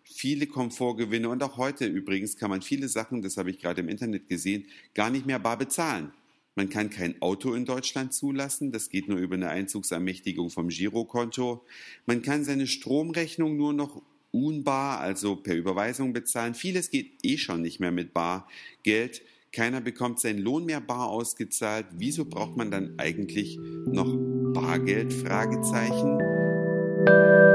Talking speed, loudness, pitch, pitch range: 155 wpm, -28 LUFS, 120 Hz, 100-135 Hz